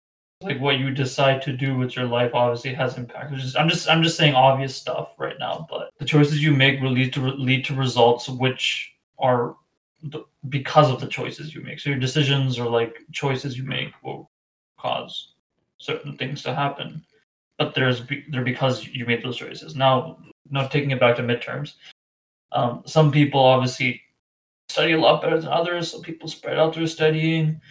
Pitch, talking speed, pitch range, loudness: 135 Hz, 195 wpm, 125-155 Hz, -22 LUFS